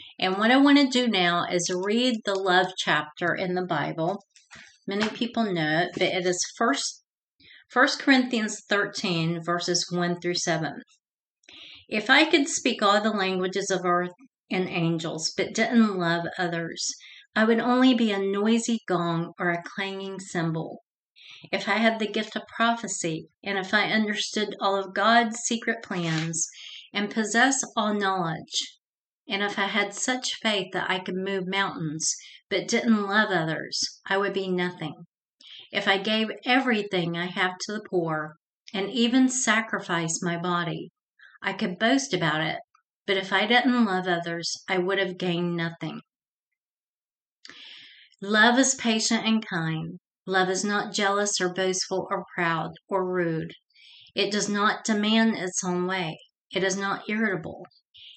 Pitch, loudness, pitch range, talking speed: 195 Hz, -25 LUFS, 180-220 Hz, 155 wpm